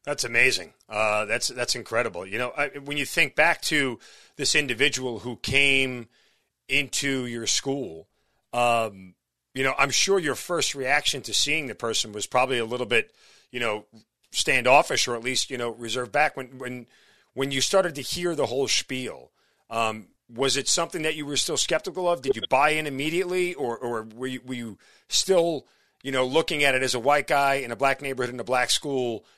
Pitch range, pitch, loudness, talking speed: 120-145 Hz, 130 Hz, -24 LUFS, 200 wpm